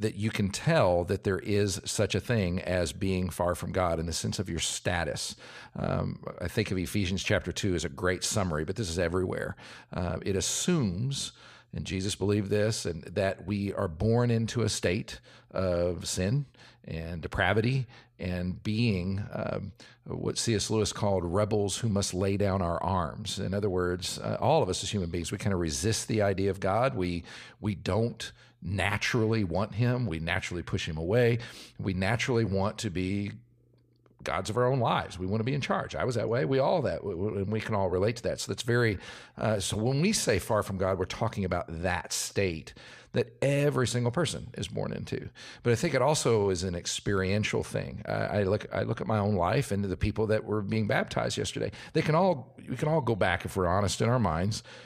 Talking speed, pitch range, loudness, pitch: 210 wpm, 90-115 Hz, -30 LUFS, 100 Hz